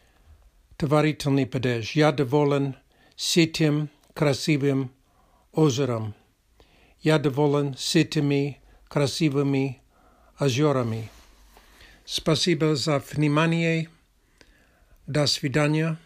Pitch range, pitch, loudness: 135-155 Hz, 145 Hz, -24 LUFS